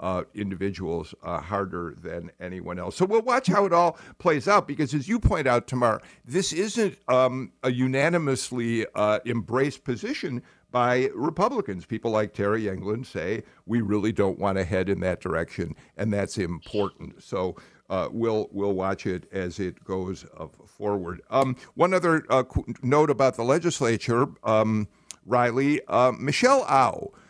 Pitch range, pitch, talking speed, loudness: 100-135 Hz, 115 Hz, 155 wpm, -25 LUFS